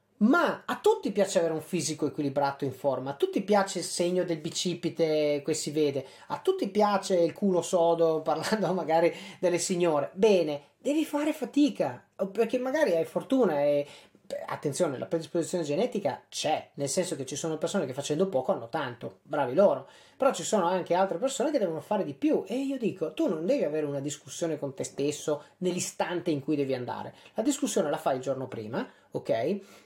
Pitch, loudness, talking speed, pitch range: 170 Hz, -29 LUFS, 185 wpm, 150-205 Hz